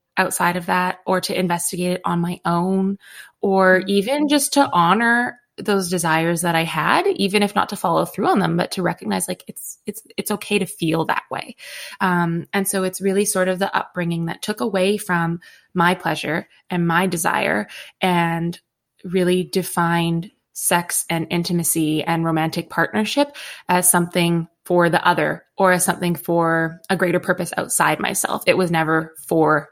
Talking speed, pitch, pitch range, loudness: 170 wpm, 180 Hz, 170-195 Hz, -19 LUFS